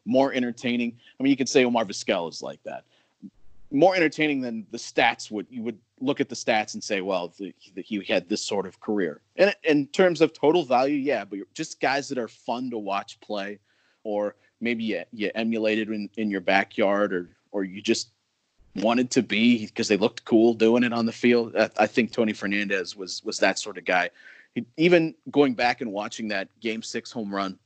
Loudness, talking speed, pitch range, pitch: -25 LUFS, 215 wpm, 105-130 Hz, 115 Hz